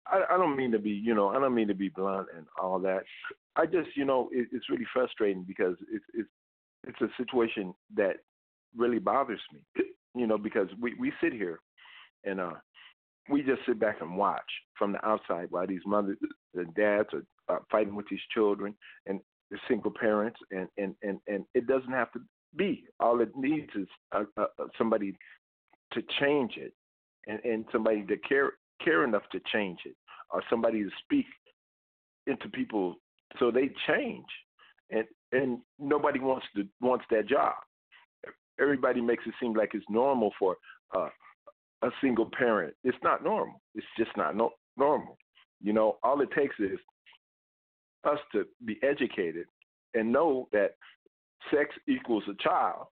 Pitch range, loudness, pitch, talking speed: 105-150 Hz, -31 LUFS, 120 Hz, 170 wpm